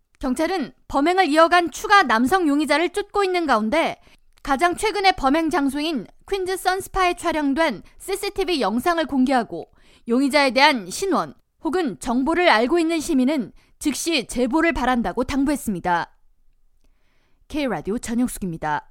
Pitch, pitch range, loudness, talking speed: 300 Hz, 250-350 Hz, -21 LUFS, 310 characters per minute